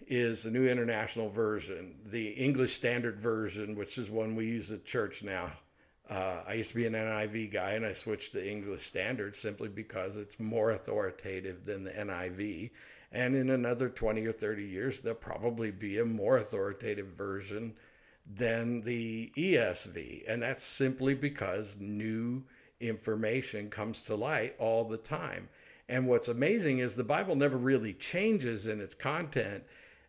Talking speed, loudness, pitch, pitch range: 160 wpm, -34 LUFS, 110 Hz, 105-120 Hz